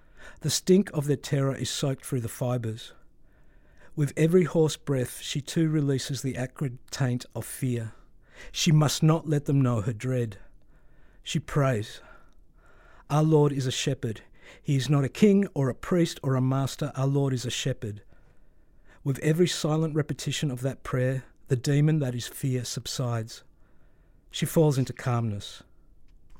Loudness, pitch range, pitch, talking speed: -27 LUFS, 125-150 Hz, 135 Hz, 160 wpm